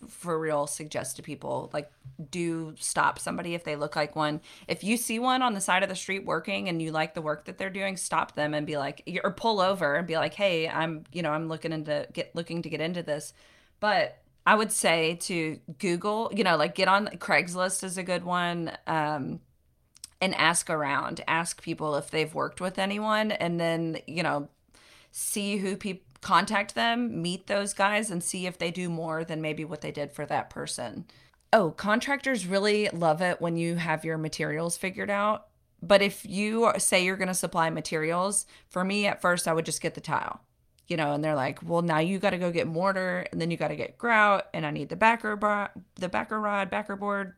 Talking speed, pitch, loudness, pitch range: 220 wpm, 175 Hz, -28 LUFS, 155-195 Hz